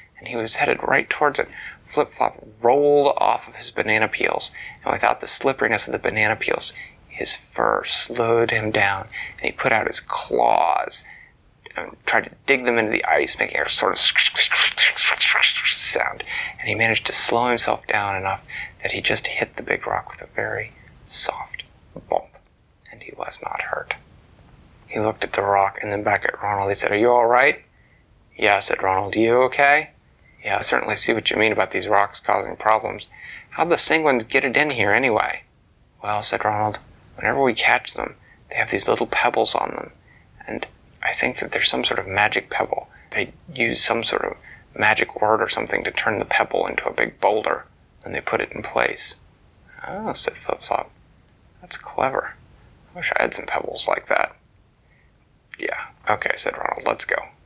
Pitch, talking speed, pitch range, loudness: 110 Hz, 185 wpm, 100-120 Hz, -20 LUFS